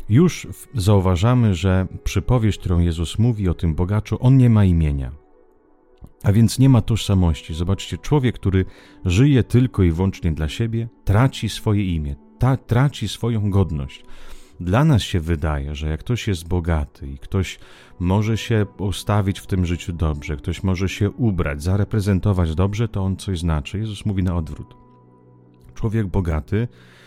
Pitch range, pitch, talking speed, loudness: 85-110 Hz, 95 Hz, 155 wpm, -20 LUFS